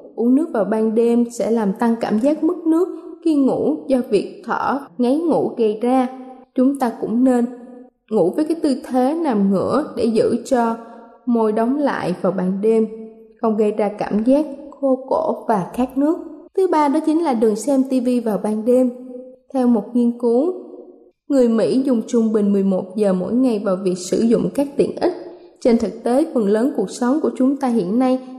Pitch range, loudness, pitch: 225-275 Hz, -19 LUFS, 245 Hz